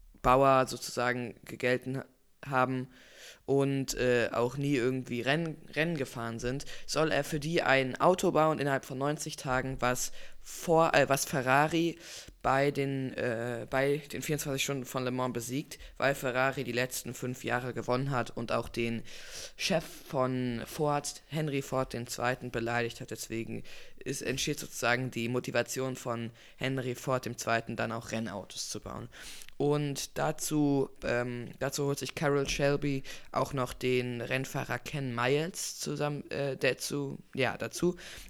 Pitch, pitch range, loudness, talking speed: 130 Hz, 125-140 Hz, -32 LUFS, 145 wpm